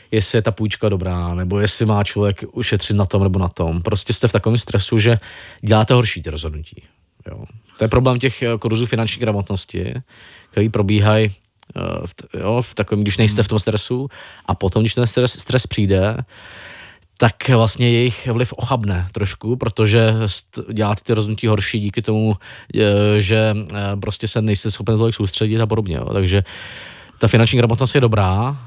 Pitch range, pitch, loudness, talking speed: 100-115 Hz, 110 Hz, -18 LUFS, 165 wpm